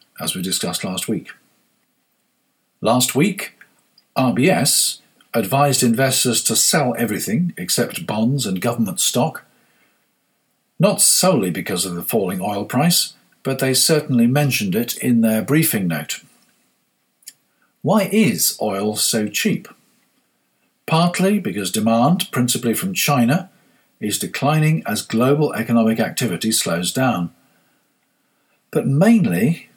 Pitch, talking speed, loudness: 145 Hz, 115 wpm, -18 LUFS